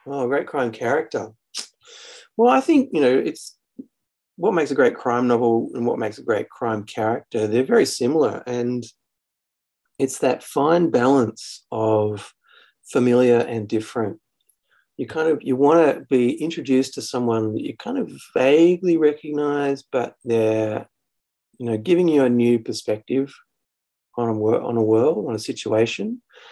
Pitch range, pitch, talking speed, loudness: 110-155 Hz, 125 Hz, 155 wpm, -21 LUFS